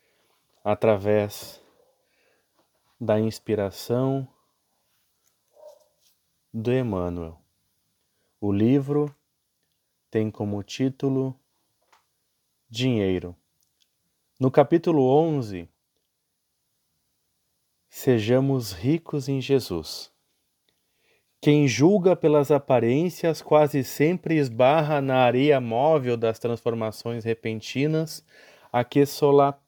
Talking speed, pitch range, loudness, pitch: 65 wpm, 110-145 Hz, -23 LUFS, 130 Hz